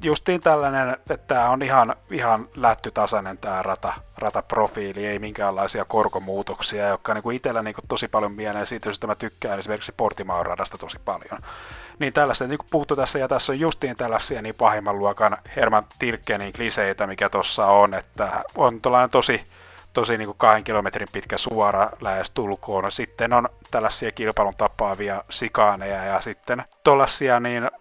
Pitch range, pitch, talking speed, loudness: 100-125 Hz, 110 Hz, 160 wpm, -22 LUFS